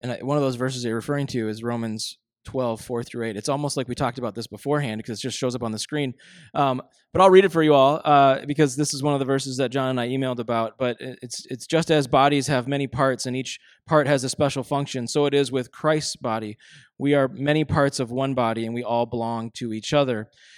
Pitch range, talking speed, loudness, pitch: 120-145 Hz, 260 wpm, -23 LUFS, 130 Hz